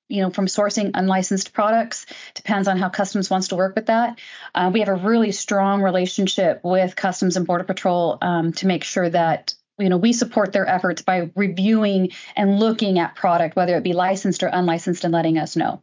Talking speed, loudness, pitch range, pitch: 205 wpm, -20 LUFS, 180-205 Hz, 190 Hz